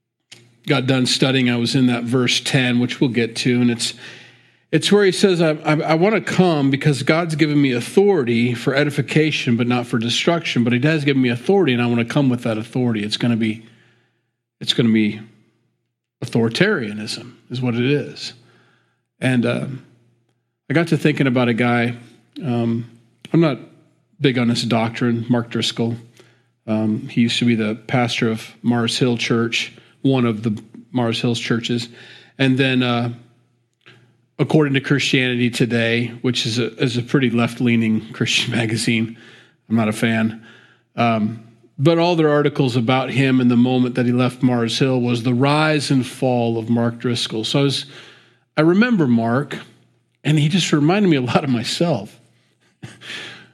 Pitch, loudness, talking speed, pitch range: 120 Hz, -18 LUFS, 175 wpm, 115-140 Hz